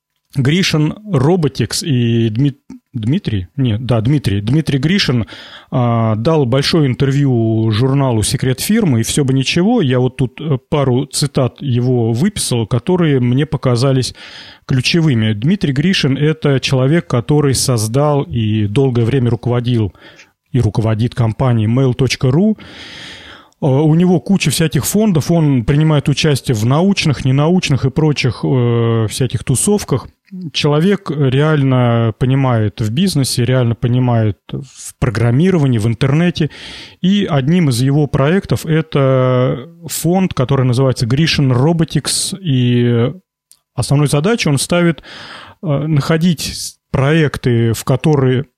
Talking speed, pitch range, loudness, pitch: 115 wpm, 125-155 Hz, -14 LUFS, 135 Hz